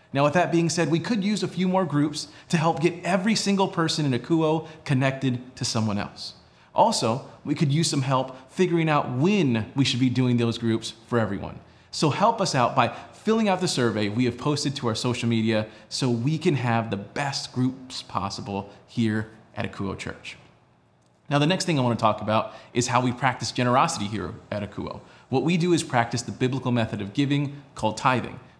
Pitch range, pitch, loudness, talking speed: 115-160 Hz, 130 Hz, -25 LUFS, 205 wpm